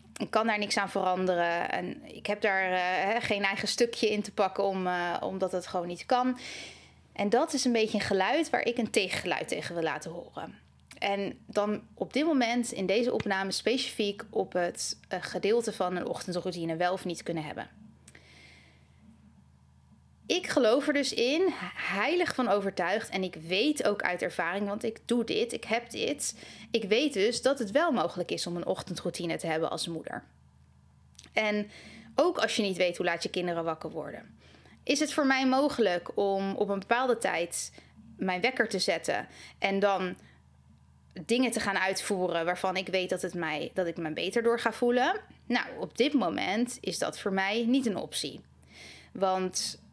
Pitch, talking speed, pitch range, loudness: 195 Hz, 185 wpm, 175-235 Hz, -30 LUFS